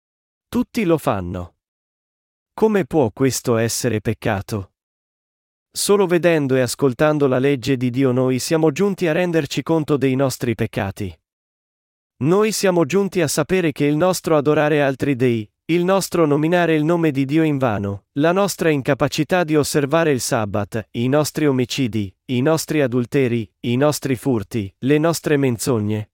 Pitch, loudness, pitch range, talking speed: 140 Hz, -19 LUFS, 120-160 Hz, 145 wpm